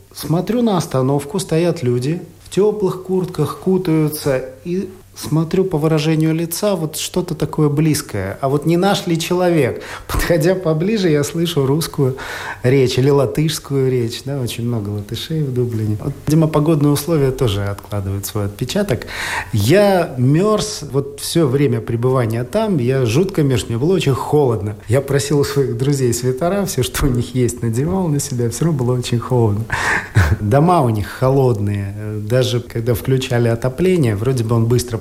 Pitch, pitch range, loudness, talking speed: 140 Hz, 120-160 Hz, -17 LUFS, 155 wpm